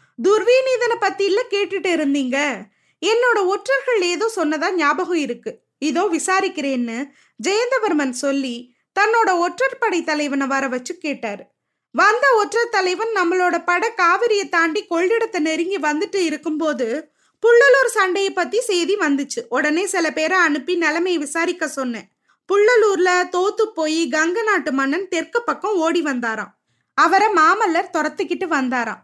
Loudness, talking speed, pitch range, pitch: -18 LUFS, 125 wpm, 300-405 Hz, 350 Hz